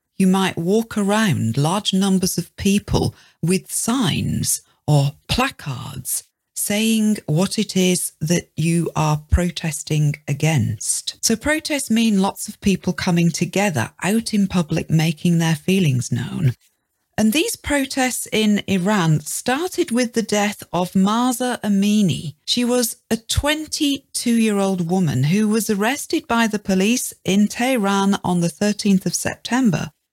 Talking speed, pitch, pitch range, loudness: 130 wpm, 195 Hz, 165-220 Hz, -19 LUFS